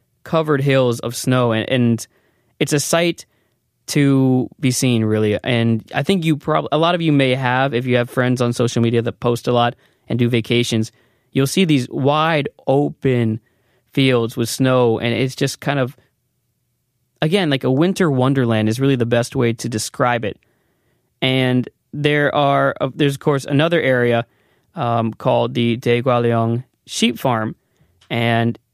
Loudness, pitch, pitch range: -18 LUFS, 125 Hz, 120-140 Hz